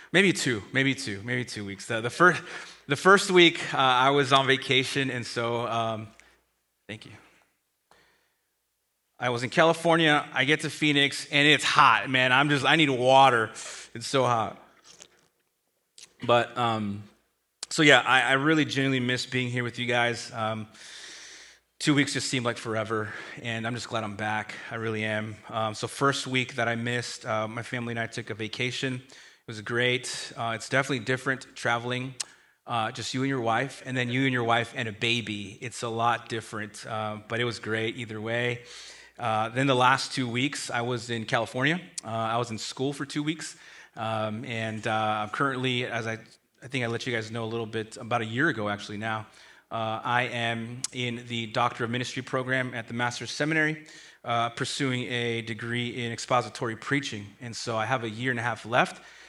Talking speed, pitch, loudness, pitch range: 195 wpm, 120 Hz, -26 LUFS, 115-130 Hz